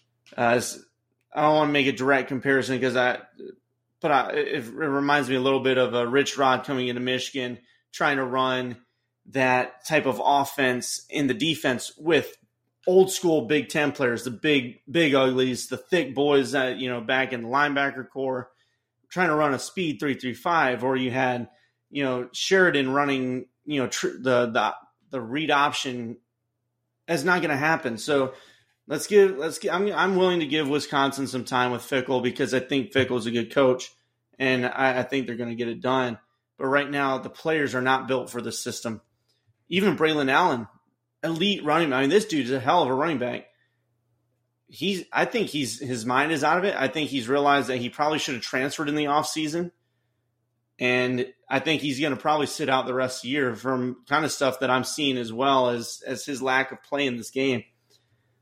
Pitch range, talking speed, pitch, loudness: 125-145 Hz, 205 wpm, 130 Hz, -24 LUFS